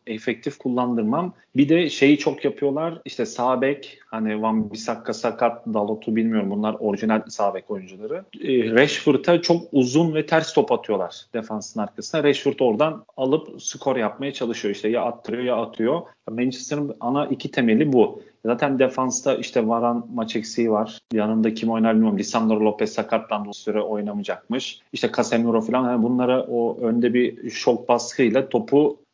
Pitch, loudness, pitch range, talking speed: 120 Hz, -22 LUFS, 110-135 Hz, 150 wpm